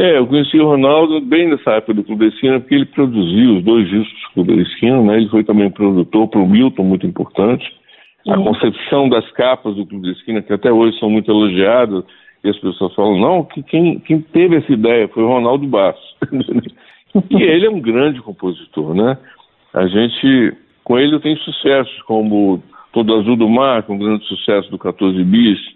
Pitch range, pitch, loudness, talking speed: 105-140 Hz, 115 Hz, -14 LUFS, 205 wpm